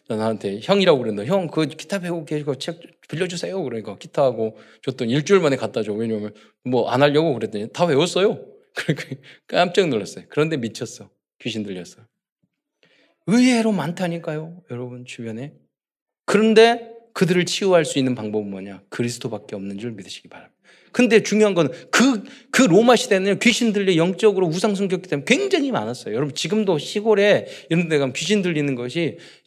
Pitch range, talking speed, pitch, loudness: 120-200 Hz, 385 characters per minute, 165 Hz, -20 LUFS